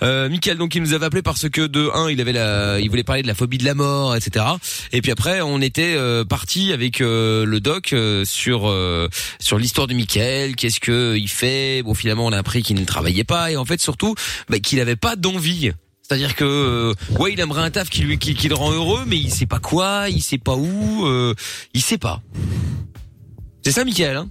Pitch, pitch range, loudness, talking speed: 125 Hz, 110-155 Hz, -19 LUFS, 235 wpm